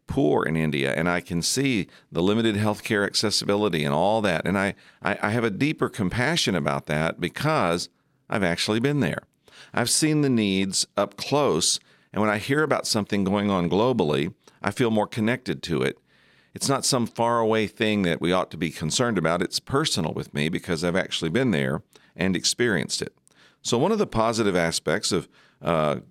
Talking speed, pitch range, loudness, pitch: 190 wpm, 85-115 Hz, -24 LUFS, 105 Hz